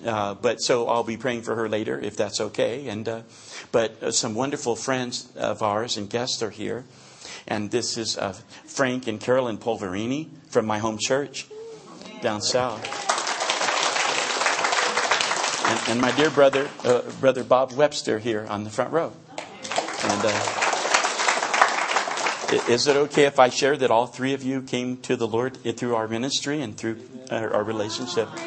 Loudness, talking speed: -24 LUFS, 170 wpm